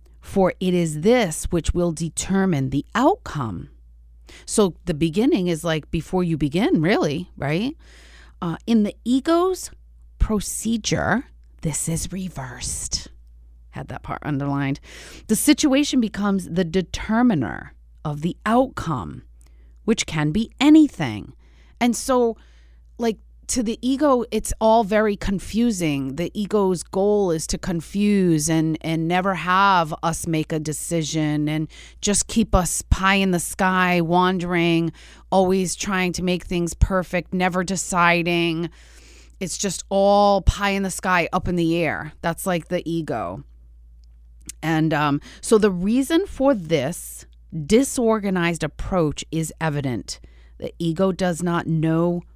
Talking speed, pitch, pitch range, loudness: 130 wpm, 175 Hz, 155-200 Hz, -21 LUFS